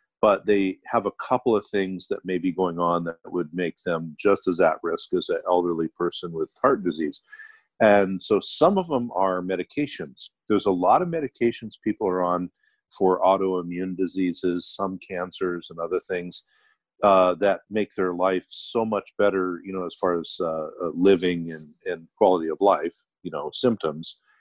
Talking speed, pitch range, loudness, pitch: 180 wpm, 90-100 Hz, -24 LUFS, 95 Hz